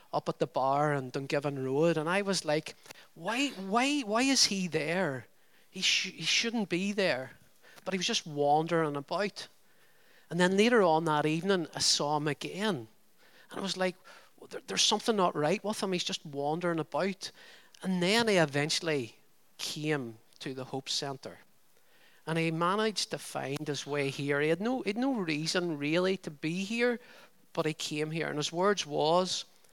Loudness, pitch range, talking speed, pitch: -30 LUFS, 150-200 Hz, 185 wpm, 170 Hz